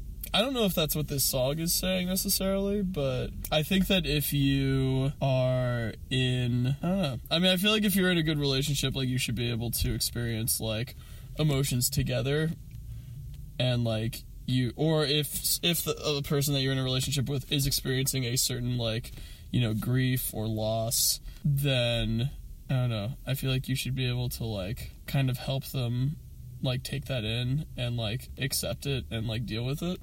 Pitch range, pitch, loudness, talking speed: 120-145 Hz, 130 Hz, -28 LUFS, 195 wpm